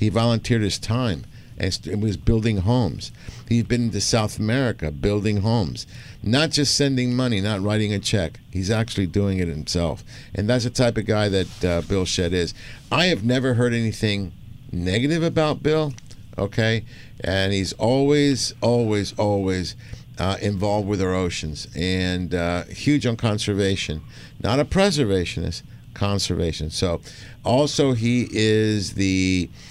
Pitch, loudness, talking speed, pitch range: 110 Hz, -22 LUFS, 145 wpm, 95-120 Hz